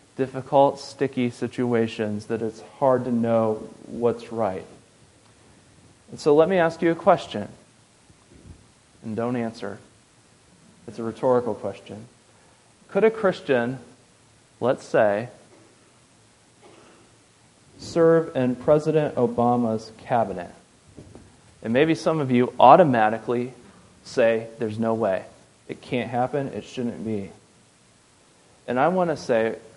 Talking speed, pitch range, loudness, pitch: 115 wpm, 110-140 Hz, -23 LUFS, 120 Hz